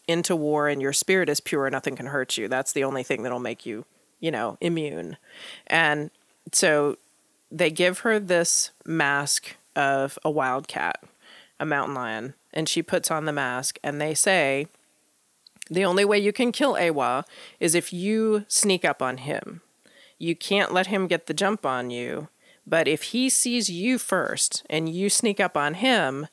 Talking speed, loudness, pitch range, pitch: 180 wpm, -24 LUFS, 140-195 Hz, 160 Hz